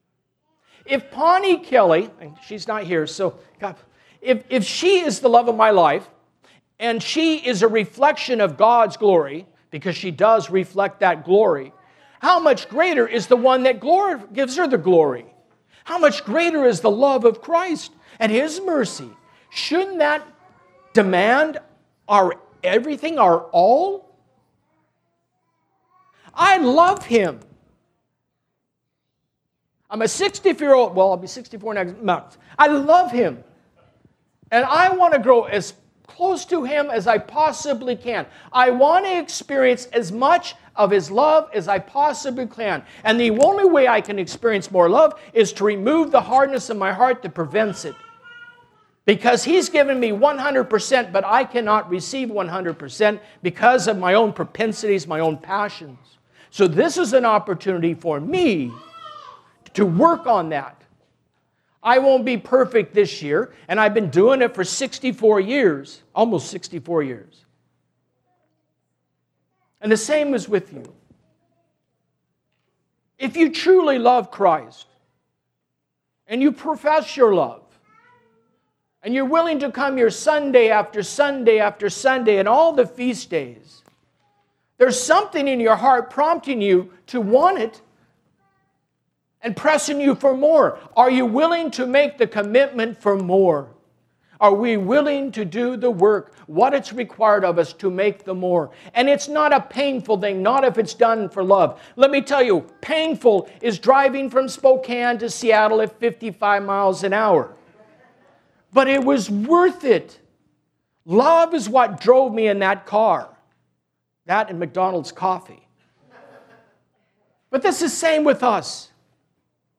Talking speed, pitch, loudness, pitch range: 145 wpm, 235 Hz, -18 LUFS, 200-285 Hz